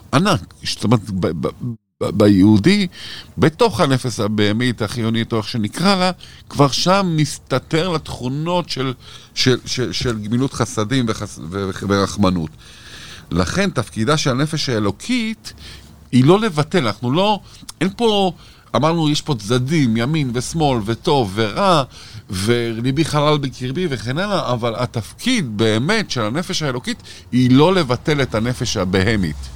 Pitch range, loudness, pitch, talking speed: 110-155 Hz, -18 LUFS, 125 Hz, 125 wpm